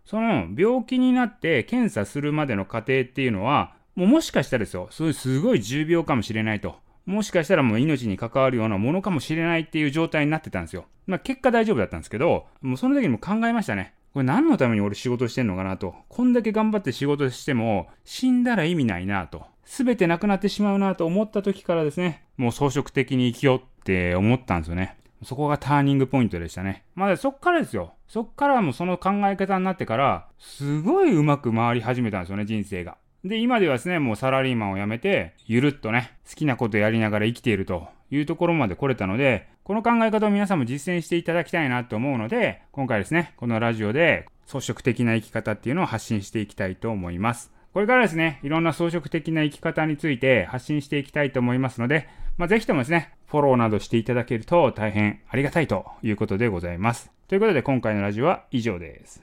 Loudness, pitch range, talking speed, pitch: -23 LUFS, 110-175 Hz, 475 characters per minute, 135 Hz